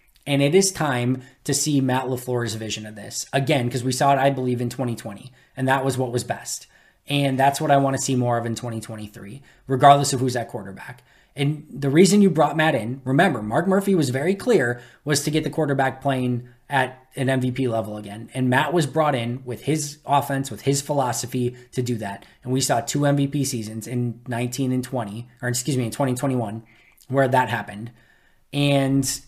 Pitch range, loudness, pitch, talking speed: 120-140 Hz, -22 LUFS, 130 Hz, 205 wpm